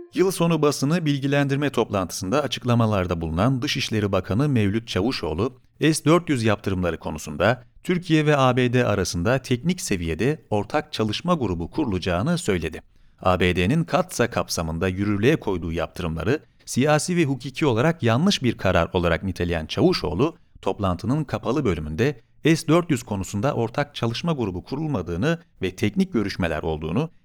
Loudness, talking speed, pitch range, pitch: -23 LUFS, 120 wpm, 95-145 Hz, 115 Hz